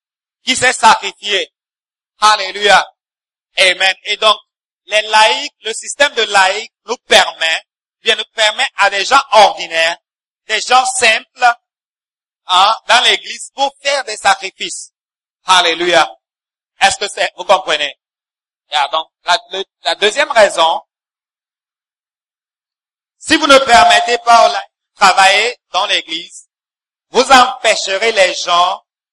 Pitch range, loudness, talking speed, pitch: 190-265 Hz, -12 LUFS, 120 wpm, 220 Hz